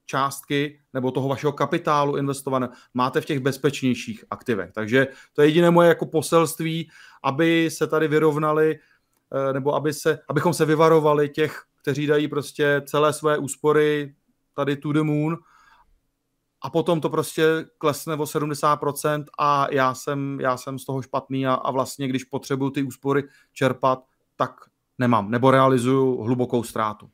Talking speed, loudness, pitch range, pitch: 150 wpm, -22 LUFS, 135-155 Hz, 145 Hz